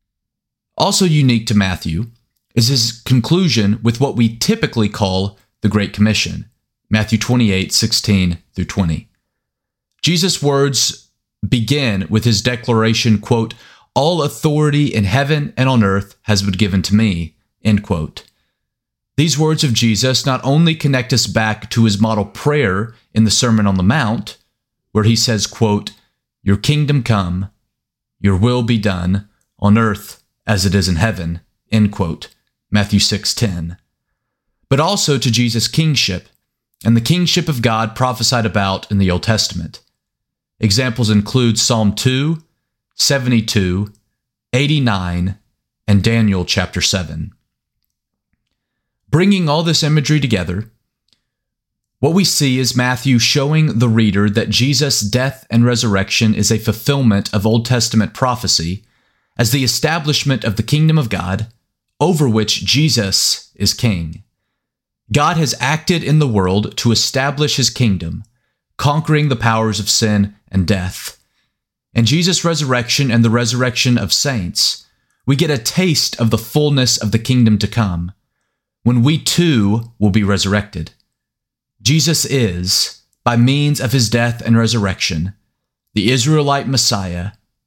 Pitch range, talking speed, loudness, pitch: 105-130 Hz, 135 wpm, -15 LUFS, 115 Hz